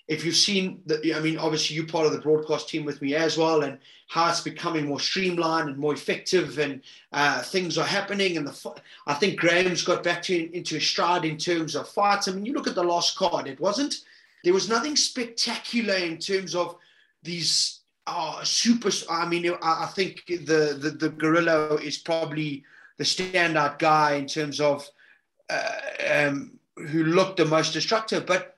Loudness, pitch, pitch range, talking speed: -25 LUFS, 165 Hz, 155-185 Hz, 190 wpm